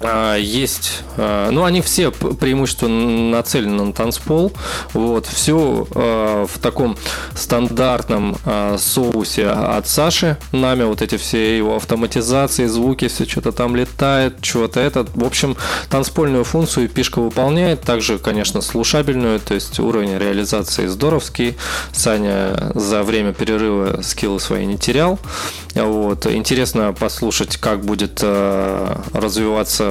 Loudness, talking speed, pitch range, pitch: -17 LUFS, 115 wpm, 105-130 Hz, 115 Hz